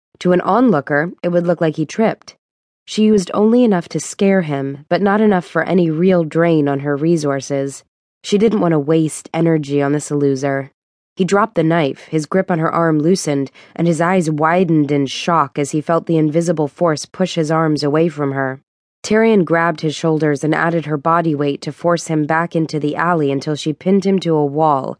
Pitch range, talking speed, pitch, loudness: 150-175 Hz, 205 wpm, 160 Hz, -16 LUFS